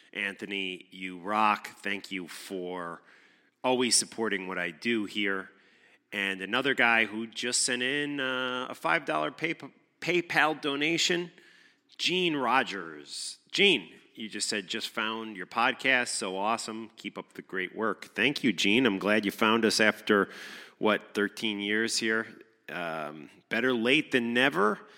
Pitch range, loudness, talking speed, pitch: 100-130 Hz, -28 LUFS, 145 wpm, 110 Hz